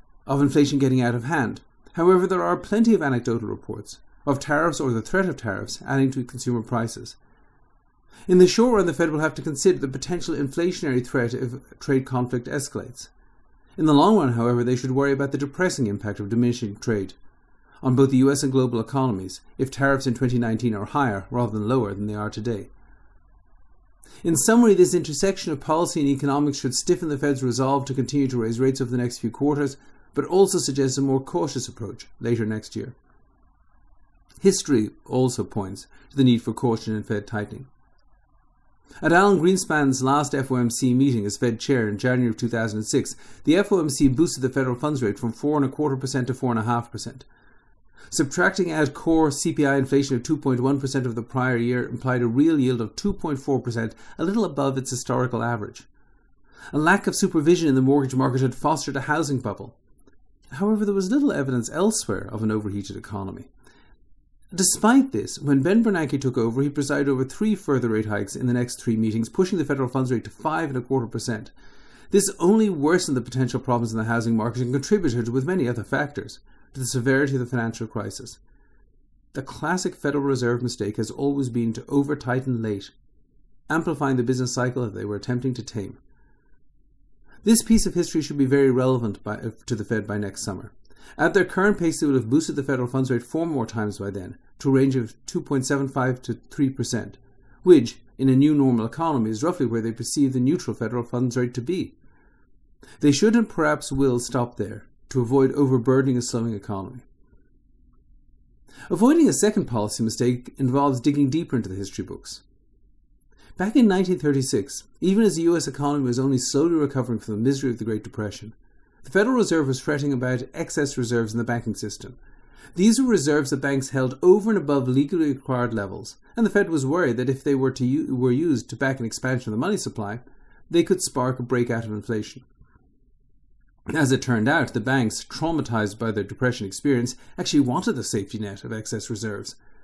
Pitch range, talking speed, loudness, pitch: 115-145 Hz, 190 wpm, -23 LUFS, 130 Hz